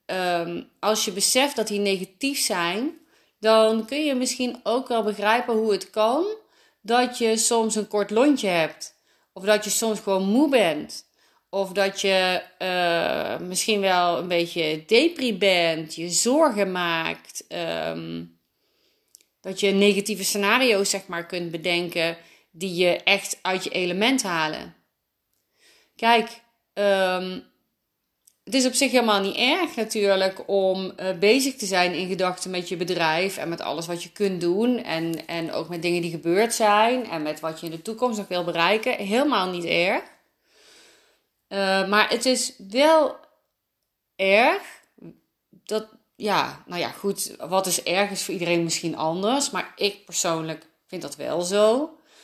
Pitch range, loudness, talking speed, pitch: 175-230 Hz, -23 LUFS, 155 wpm, 200 Hz